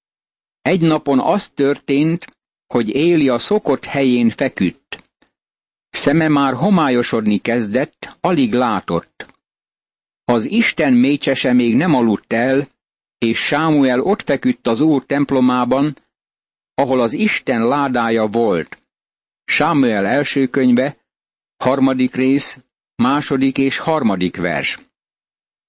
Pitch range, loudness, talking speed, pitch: 125-145 Hz, -16 LUFS, 105 wpm, 135 Hz